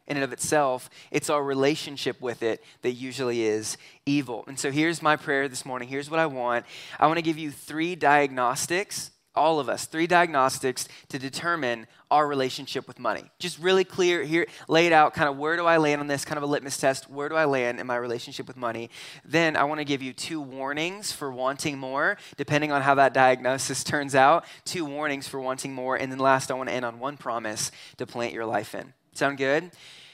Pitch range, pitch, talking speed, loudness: 130-155 Hz, 140 Hz, 220 wpm, -26 LUFS